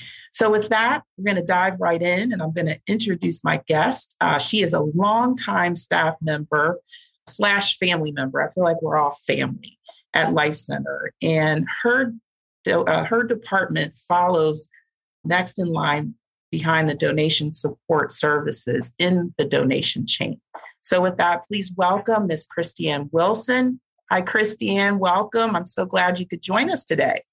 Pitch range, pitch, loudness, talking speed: 155-215 Hz, 180 Hz, -21 LUFS, 155 wpm